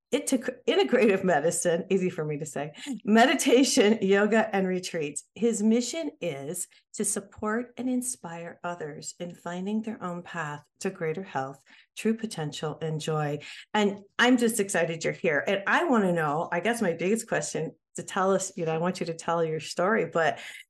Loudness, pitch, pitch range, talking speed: -27 LUFS, 185 Hz, 165-220 Hz, 180 wpm